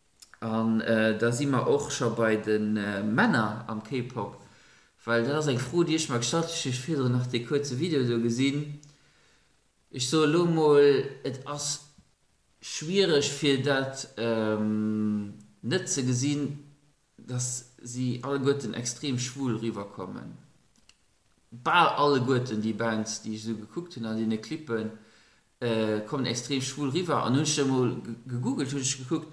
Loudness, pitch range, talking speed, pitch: -28 LUFS, 110-145 Hz, 130 wpm, 125 Hz